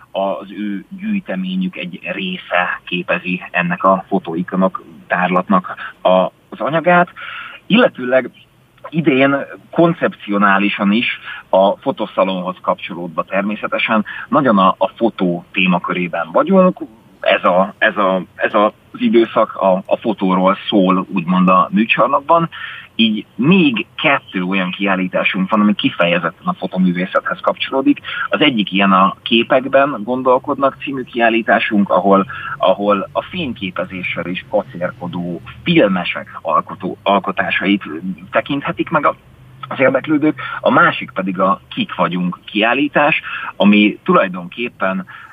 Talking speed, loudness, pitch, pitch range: 105 wpm, -16 LUFS, 105 Hz, 95-140 Hz